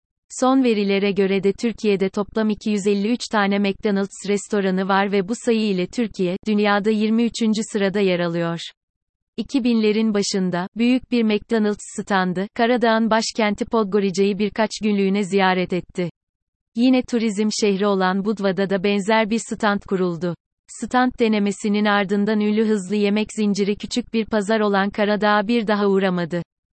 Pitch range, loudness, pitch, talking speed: 195-225 Hz, -20 LUFS, 210 Hz, 130 wpm